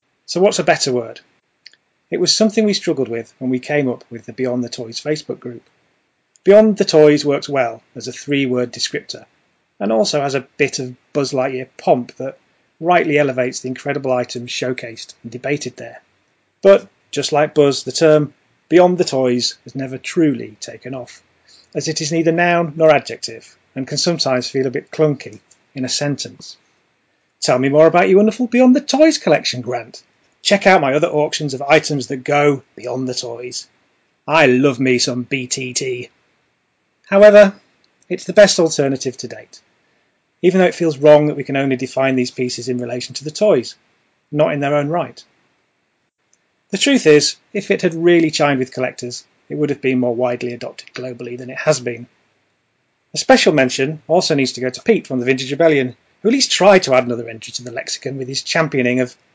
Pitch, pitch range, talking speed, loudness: 140 Hz, 125-165 Hz, 190 wpm, -16 LUFS